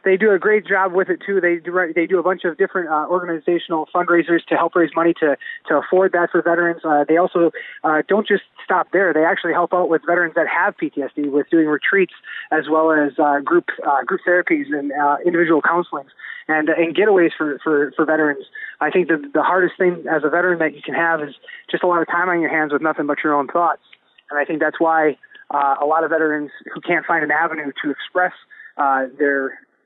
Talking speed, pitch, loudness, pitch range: 235 wpm, 165 Hz, -18 LUFS, 155-180 Hz